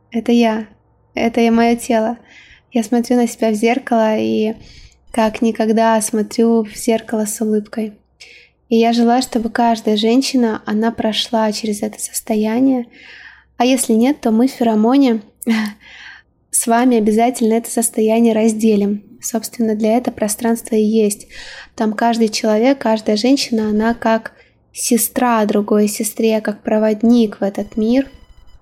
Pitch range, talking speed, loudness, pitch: 220-235 Hz, 135 wpm, -16 LUFS, 225 Hz